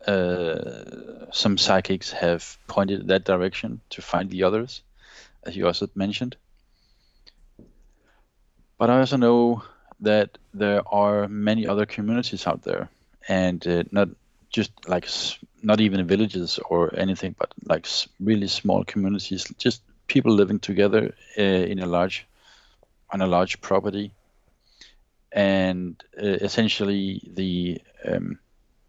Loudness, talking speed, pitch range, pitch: -24 LUFS, 125 wpm, 95-105 Hz, 100 Hz